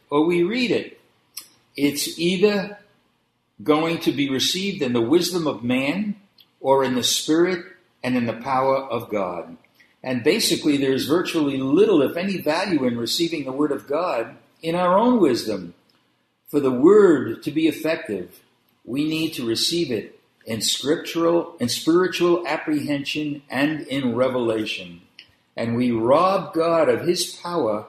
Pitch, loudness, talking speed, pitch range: 160 Hz, -21 LUFS, 150 wpm, 130-185 Hz